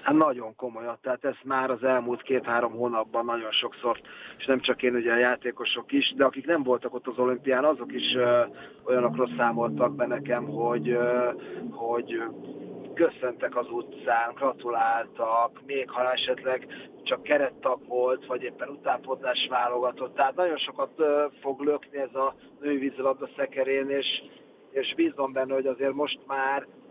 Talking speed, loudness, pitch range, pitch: 150 wpm, -27 LUFS, 120-135 Hz, 125 Hz